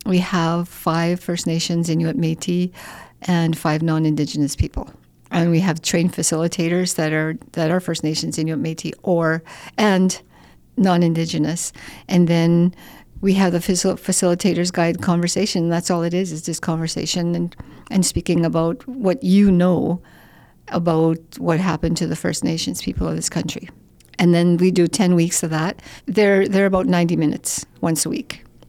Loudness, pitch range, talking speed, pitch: -19 LUFS, 165-180 Hz, 160 wpm, 170 Hz